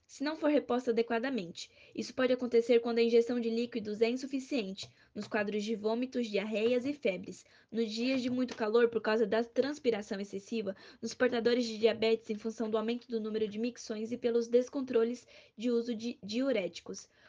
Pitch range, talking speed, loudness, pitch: 225-245 Hz, 175 wpm, -33 LUFS, 235 Hz